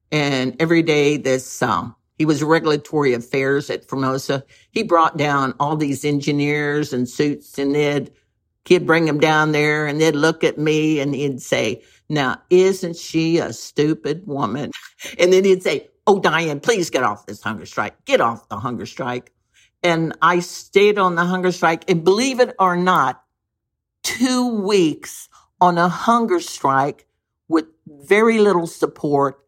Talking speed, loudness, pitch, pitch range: 160 wpm, -18 LUFS, 155 Hz, 140-180 Hz